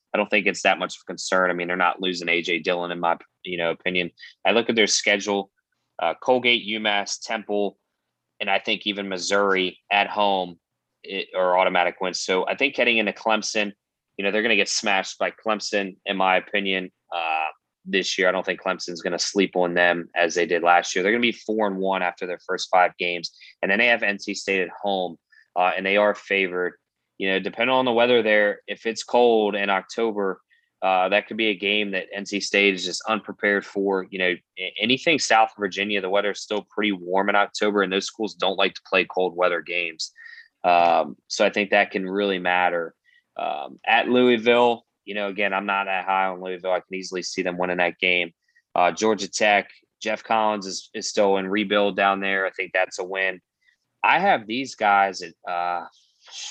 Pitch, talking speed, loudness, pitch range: 100 Hz, 210 wpm, -22 LUFS, 90-105 Hz